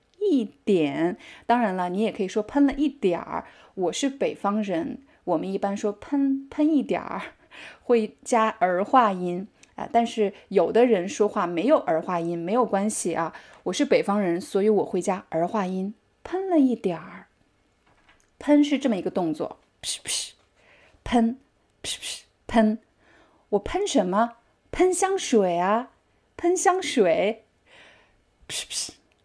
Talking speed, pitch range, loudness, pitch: 200 characters per minute, 190-270 Hz, -25 LUFS, 220 Hz